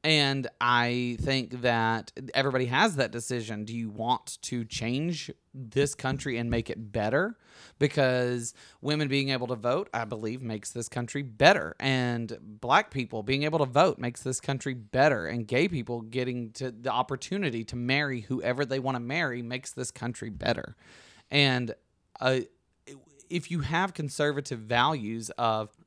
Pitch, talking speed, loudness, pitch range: 125 Hz, 160 wpm, -29 LUFS, 120-140 Hz